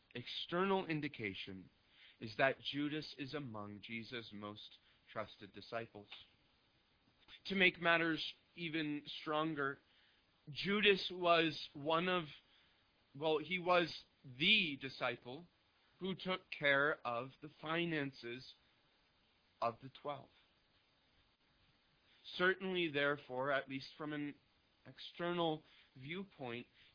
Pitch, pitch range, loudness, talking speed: 145 Hz, 120-165 Hz, -39 LUFS, 95 wpm